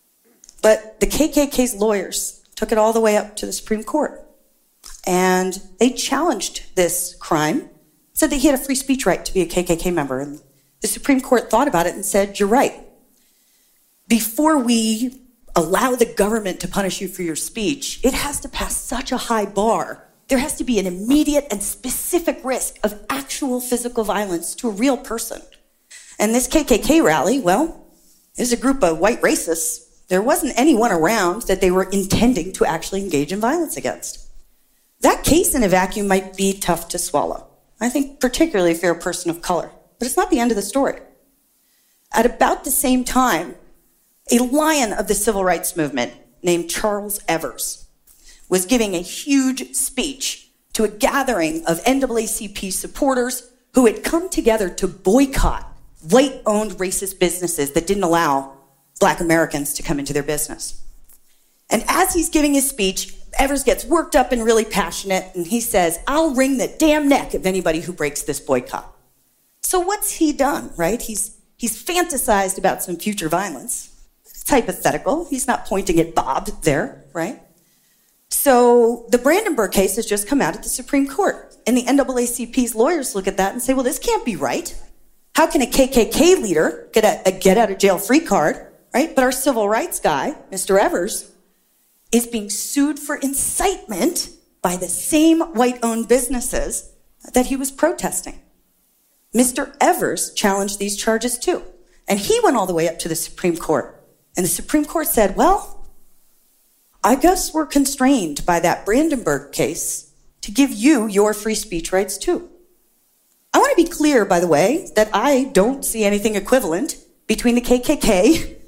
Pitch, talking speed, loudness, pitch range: 230 Hz, 175 wpm, -19 LUFS, 190-275 Hz